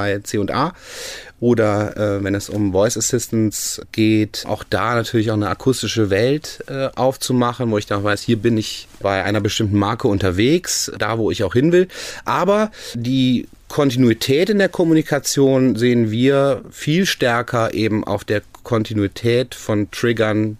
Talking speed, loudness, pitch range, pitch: 155 wpm, -18 LUFS, 105-130 Hz, 115 Hz